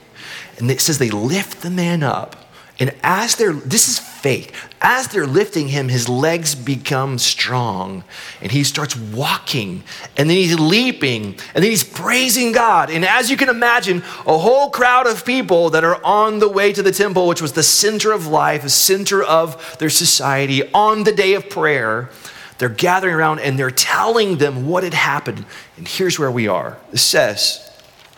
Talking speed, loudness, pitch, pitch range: 185 wpm, -15 LUFS, 165 Hz, 135-200 Hz